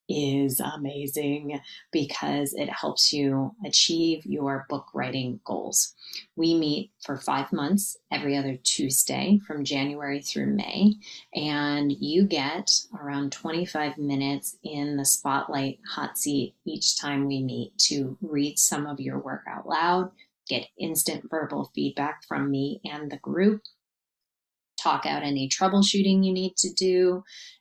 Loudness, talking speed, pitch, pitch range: -26 LUFS, 135 wpm, 145 Hz, 140-175 Hz